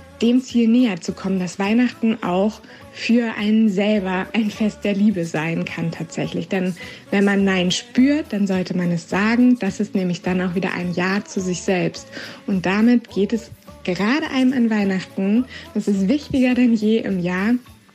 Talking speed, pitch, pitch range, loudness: 180 wpm, 205 Hz, 185-230 Hz, -20 LUFS